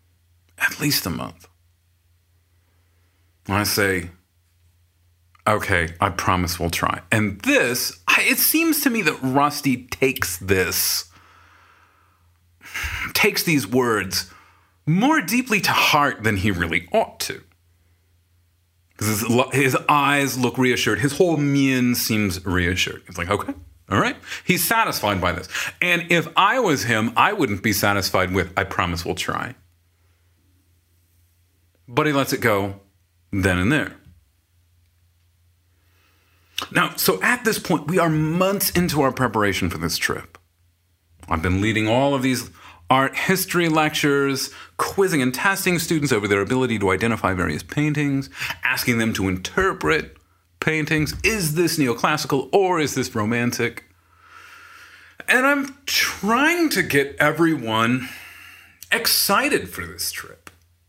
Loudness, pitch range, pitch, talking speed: -20 LUFS, 90-145 Hz, 105 Hz, 130 wpm